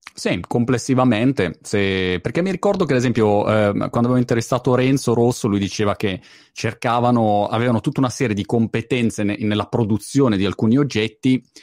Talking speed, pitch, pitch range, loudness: 160 wpm, 120 Hz, 105-130 Hz, -19 LUFS